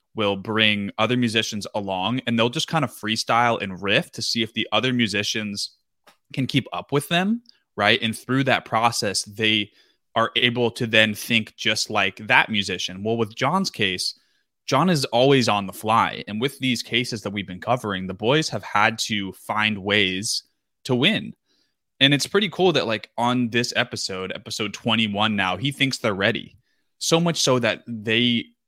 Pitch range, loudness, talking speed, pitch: 105-130 Hz, -22 LUFS, 180 wpm, 115 Hz